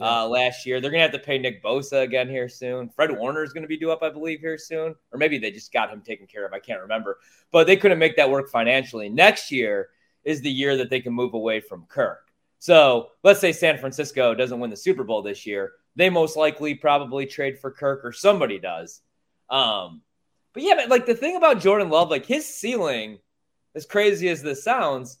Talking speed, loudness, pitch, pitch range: 230 wpm, -21 LUFS, 145 Hz, 125-175 Hz